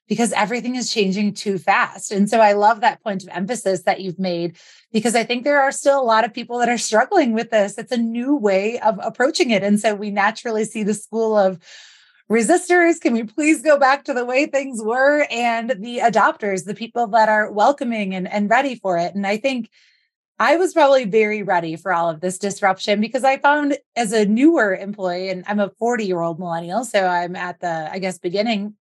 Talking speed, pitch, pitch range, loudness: 215 wpm, 220 Hz, 195-245 Hz, -19 LUFS